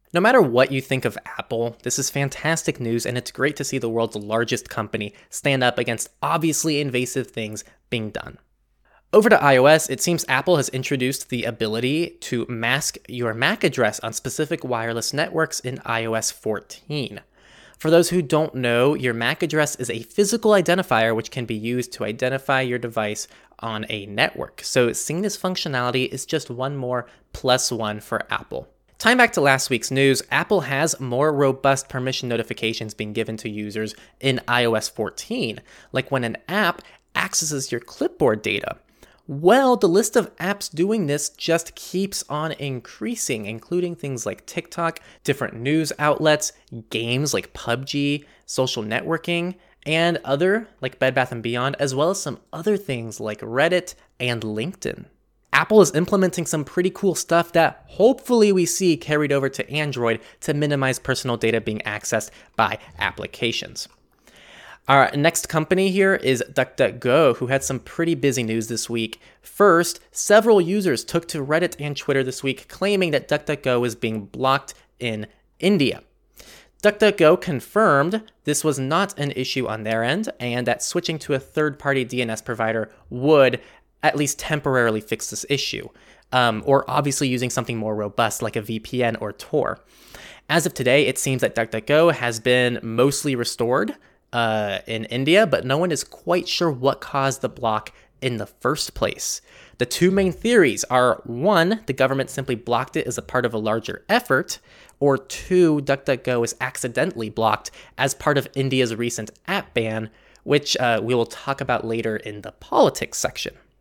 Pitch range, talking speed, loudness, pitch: 115-155 Hz, 165 wpm, -21 LUFS, 130 Hz